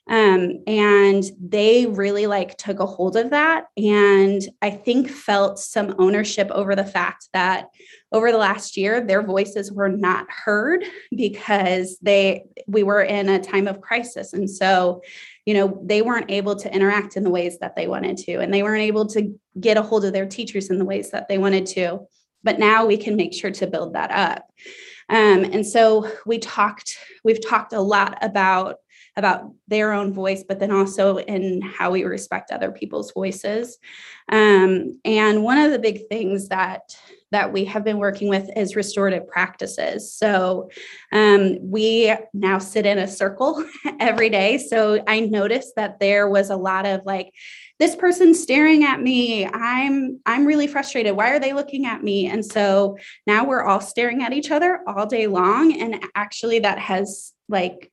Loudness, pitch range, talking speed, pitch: -20 LUFS, 195-225 Hz, 180 wpm, 205 Hz